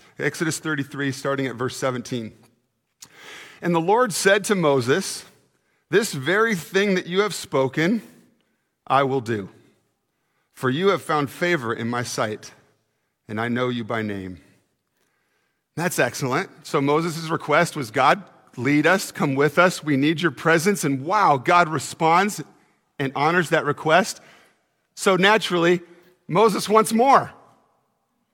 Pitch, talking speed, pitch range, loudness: 150 Hz, 140 wpm, 130-175 Hz, -21 LUFS